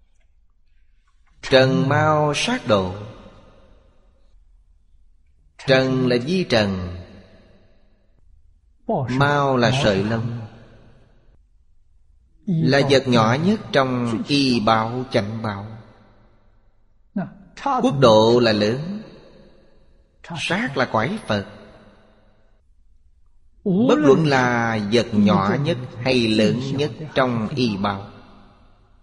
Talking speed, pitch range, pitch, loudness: 85 wpm, 95-130 Hz, 110 Hz, -19 LUFS